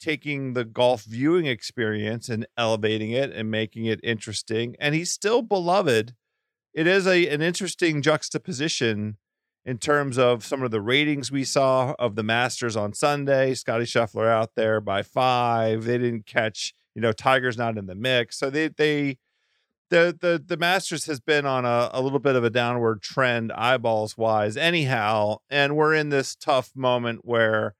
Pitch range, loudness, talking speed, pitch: 115-145 Hz, -23 LUFS, 175 wpm, 125 Hz